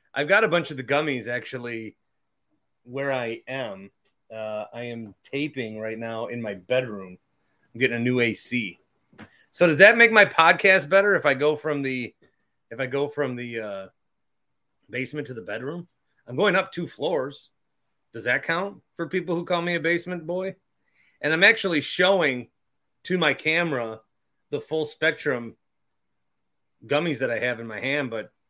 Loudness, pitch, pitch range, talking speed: -23 LUFS, 140 Hz, 120-170 Hz, 170 wpm